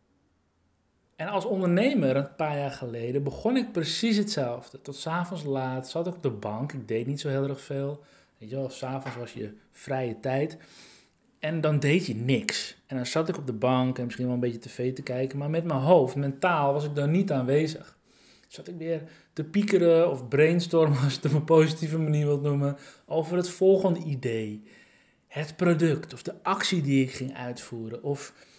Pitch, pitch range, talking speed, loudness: 140 Hz, 130-165 Hz, 195 wpm, -27 LUFS